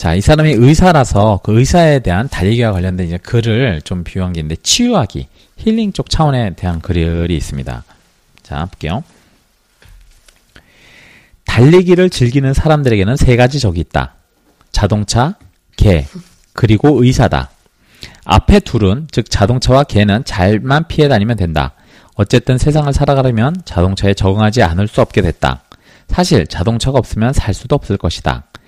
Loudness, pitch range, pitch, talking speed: -13 LUFS, 90-135 Hz, 110 Hz, 310 characters per minute